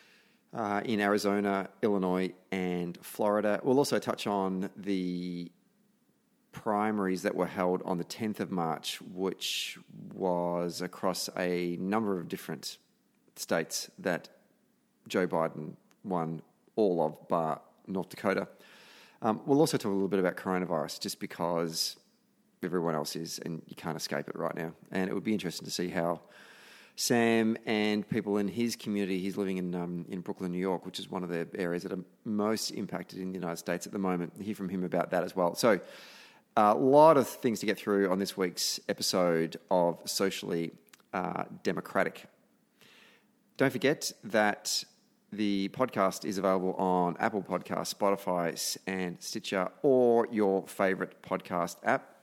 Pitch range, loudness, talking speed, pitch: 90-105 Hz, -31 LUFS, 160 wpm, 95 Hz